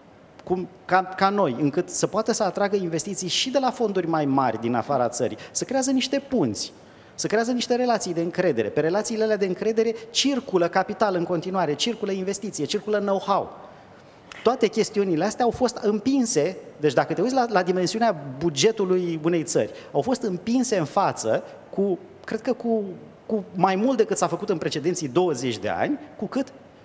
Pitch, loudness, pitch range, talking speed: 200 Hz, -24 LUFS, 175-230 Hz, 180 wpm